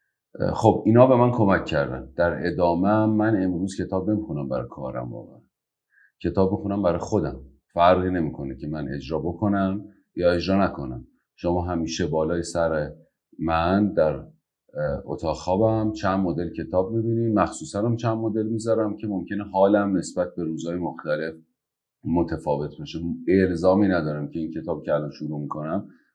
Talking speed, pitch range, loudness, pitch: 145 wpm, 80-100 Hz, -24 LUFS, 90 Hz